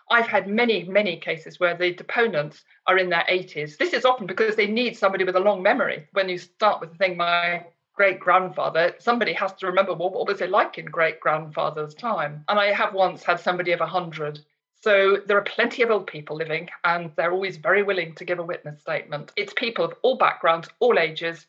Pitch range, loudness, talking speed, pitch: 165-205 Hz, -23 LUFS, 215 wpm, 180 Hz